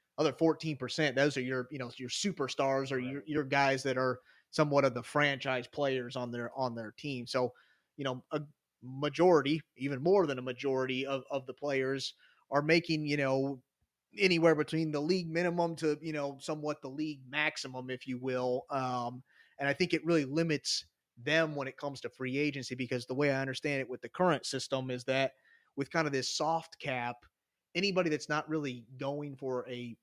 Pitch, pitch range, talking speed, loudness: 140 Hz, 130-150 Hz, 195 wpm, -33 LUFS